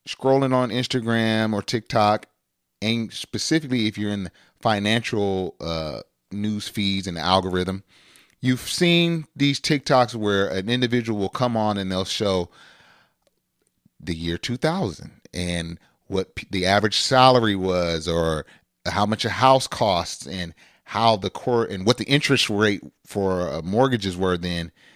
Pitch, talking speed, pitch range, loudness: 105 Hz, 145 wpm, 95-125 Hz, -22 LUFS